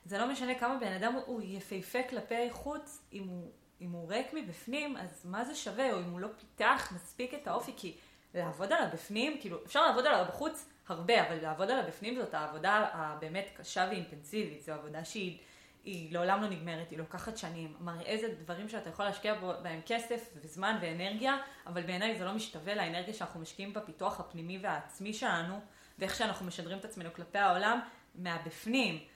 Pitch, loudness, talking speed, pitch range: 195 Hz, -36 LUFS, 180 wpm, 175-225 Hz